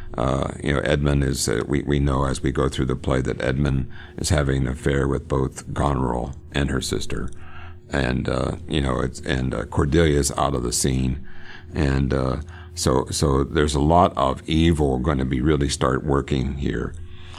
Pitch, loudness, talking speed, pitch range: 70 Hz, -22 LUFS, 190 wpm, 65-75 Hz